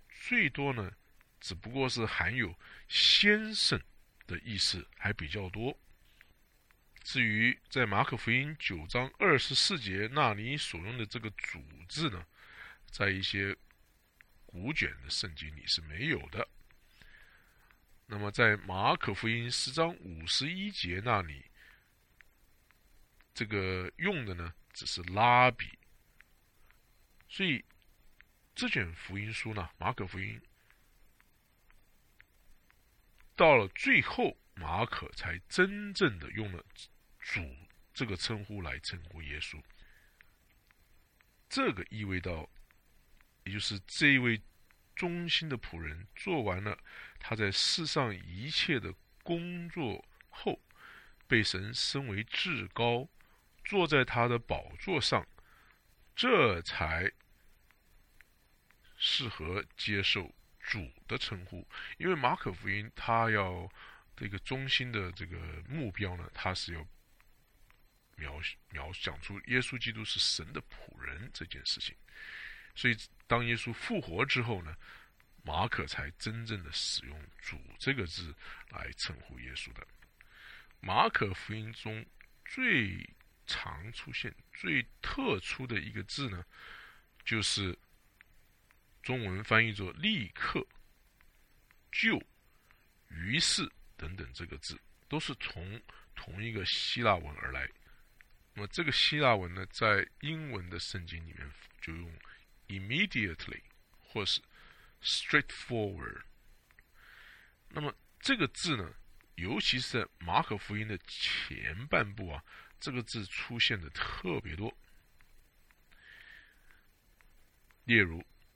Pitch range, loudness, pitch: 90-120 Hz, -33 LUFS, 100 Hz